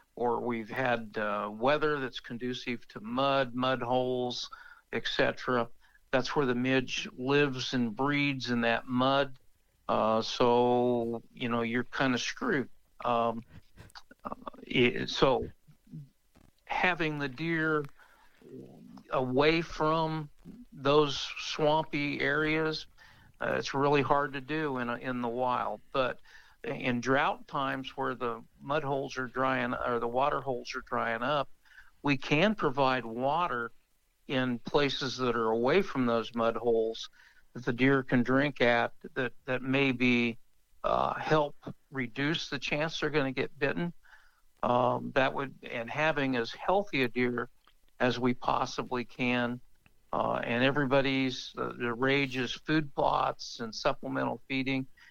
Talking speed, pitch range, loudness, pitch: 140 wpm, 120-145 Hz, -30 LUFS, 130 Hz